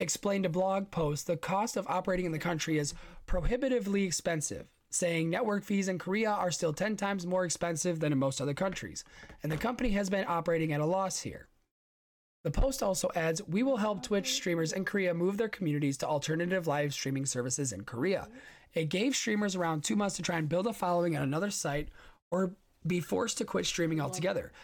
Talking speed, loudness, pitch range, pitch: 200 wpm, -32 LUFS, 160-200 Hz, 180 Hz